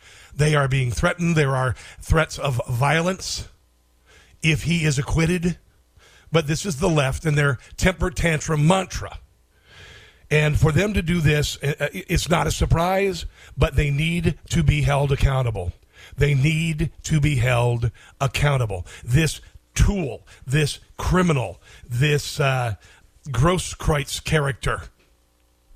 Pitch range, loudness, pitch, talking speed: 105-155 Hz, -22 LUFS, 140 Hz, 130 wpm